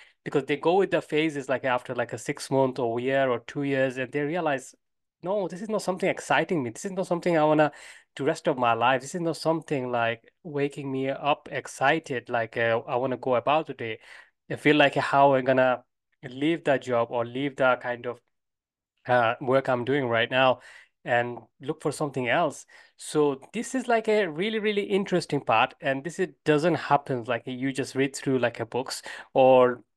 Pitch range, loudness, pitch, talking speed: 125-155 Hz, -26 LUFS, 135 Hz, 215 wpm